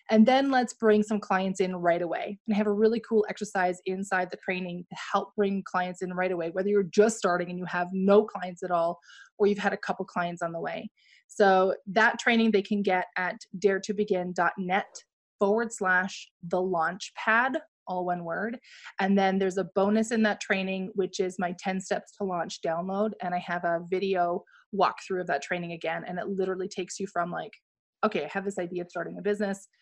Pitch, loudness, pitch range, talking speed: 190 Hz, -28 LUFS, 180-210 Hz, 210 wpm